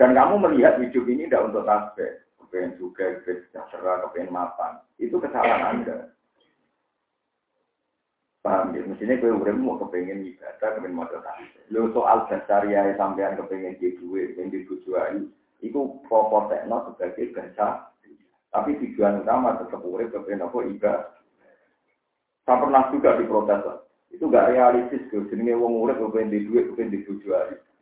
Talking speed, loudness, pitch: 145 wpm, -24 LUFS, 125 Hz